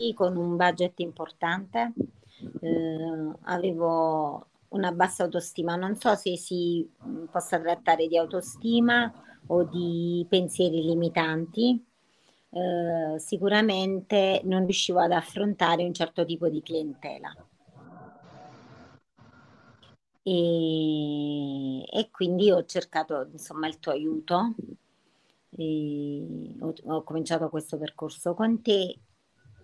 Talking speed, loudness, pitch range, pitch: 100 wpm, -27 LUFS, 160-190 Hz, 175 Hz